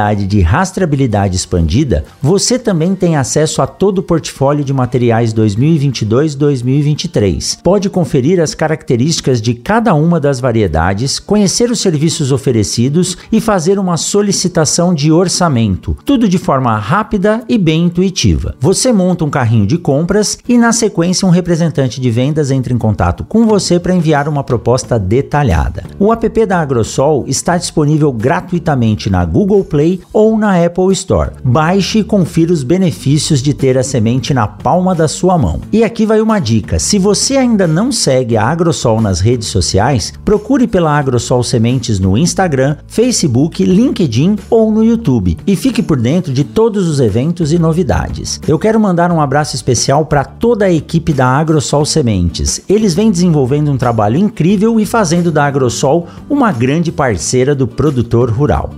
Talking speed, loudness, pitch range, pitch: 160 wpm, -12 LUFS, 125-190 Hz, 155 Hz